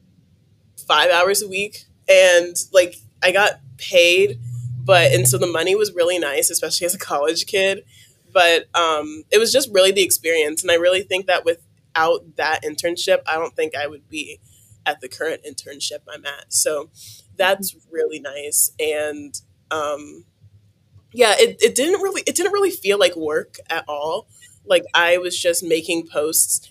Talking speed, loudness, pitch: 170 wpm, -18 LUFS, 175 Hz